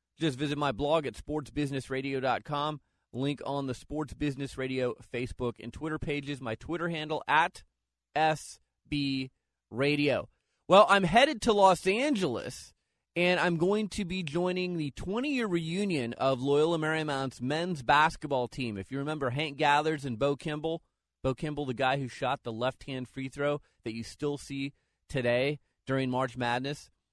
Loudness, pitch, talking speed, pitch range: -30 LUFS, 145 Hz, 155 wpm, 130-160 Hz